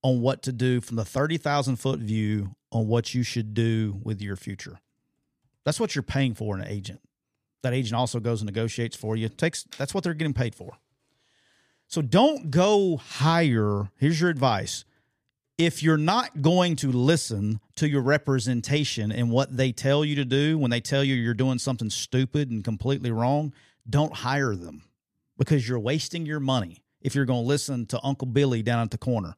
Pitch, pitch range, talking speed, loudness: 130 Hz, 115-145 Hz, 190 wpm, -26 LUFS